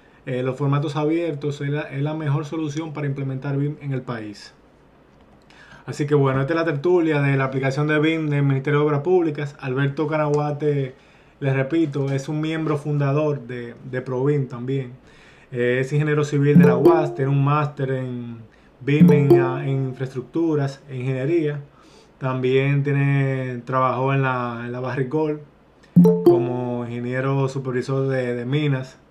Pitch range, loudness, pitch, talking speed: 130-150 Hz, -21 LUFS, 140 Hz, 155 wpm